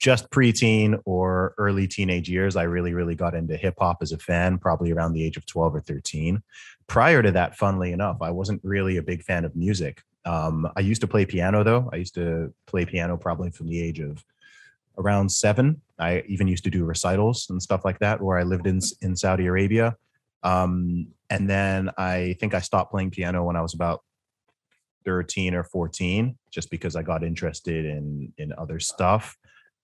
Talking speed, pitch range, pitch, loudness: 195 wpm, 85-100 Hz, 90 Hz, -24 LUFS